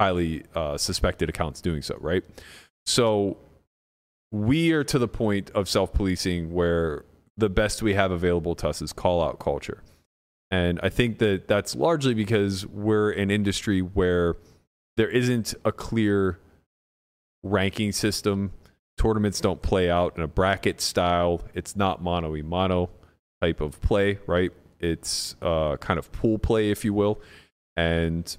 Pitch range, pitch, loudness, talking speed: 85-105 Hz, 95 Hz, -25 LUFS, 145 wpm